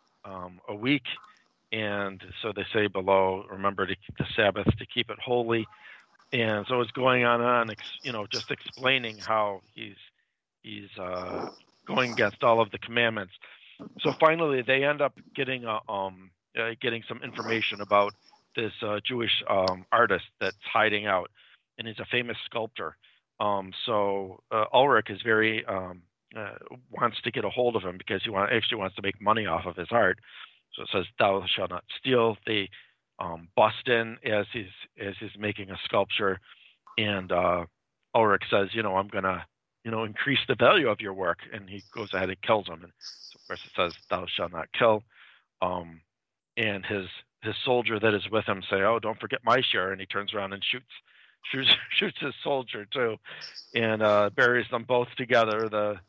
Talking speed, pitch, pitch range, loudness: 190 wpm, 105 Hz, 95-115 Hz, -27 LUFS